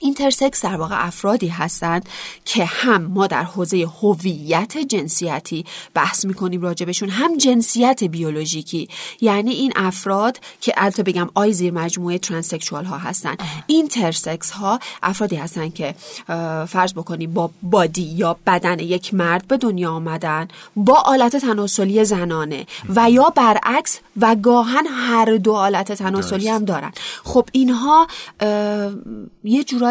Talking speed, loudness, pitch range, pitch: 130 wpm, -18 LUFS, 170-230 Hz, 195 Hz